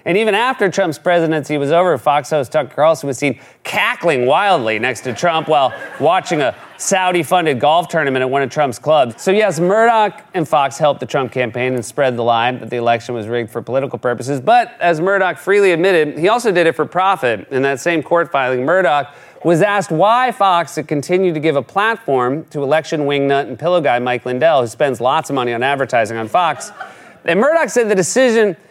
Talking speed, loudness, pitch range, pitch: 205 wpm, -15 LUFS, 130-185 Hz, 155 Hz